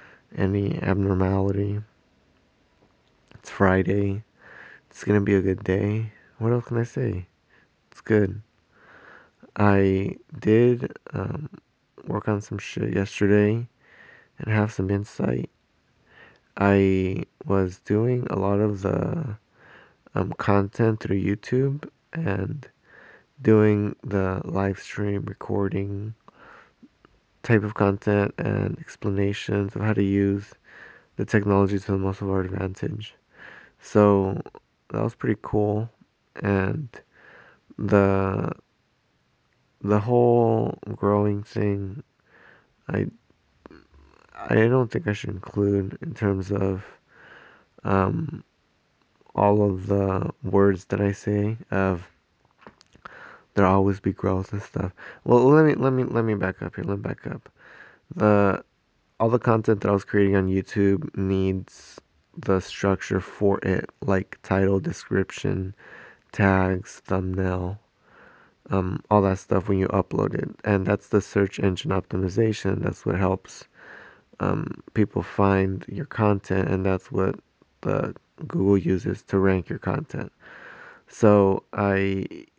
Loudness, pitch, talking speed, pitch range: -24 LUFS, 100 Hz, 120 wpm, 95-105 Hz